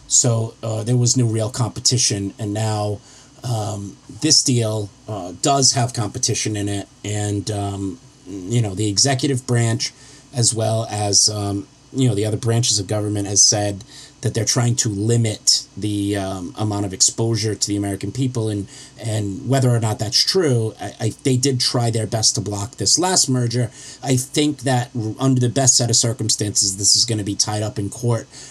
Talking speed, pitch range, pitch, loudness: 185 wpm, 105-130 Hz, 115 Hz, -18 LUFS